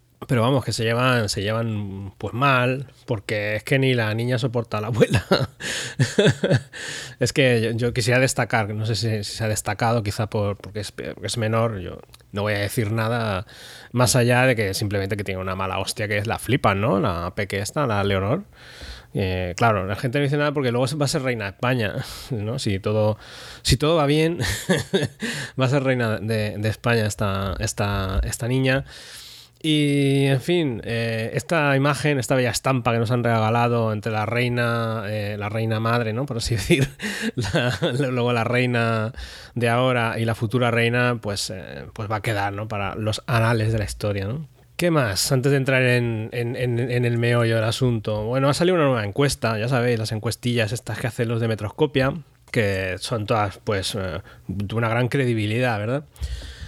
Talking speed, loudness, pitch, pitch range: 195 wpm, -22 LUFS, 115 Hz, 105-130 Hz